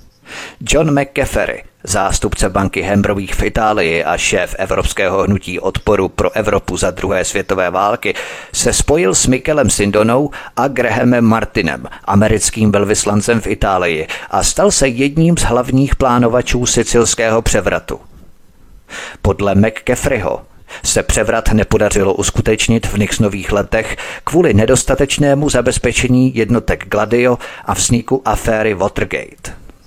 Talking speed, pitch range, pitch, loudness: 115 wpm, 105-125 Hz, 115 Hz, -14 LUFS